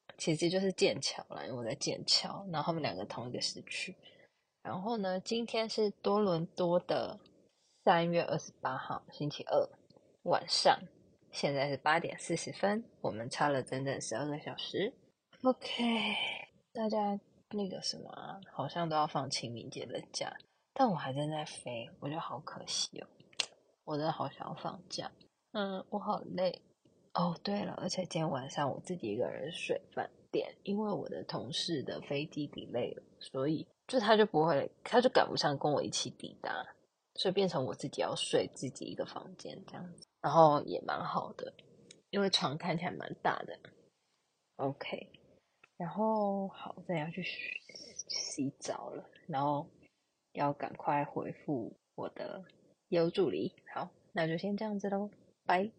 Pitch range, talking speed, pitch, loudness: 150-205 Hz, 240 characters per minute, 180 Hz, -35 LUFS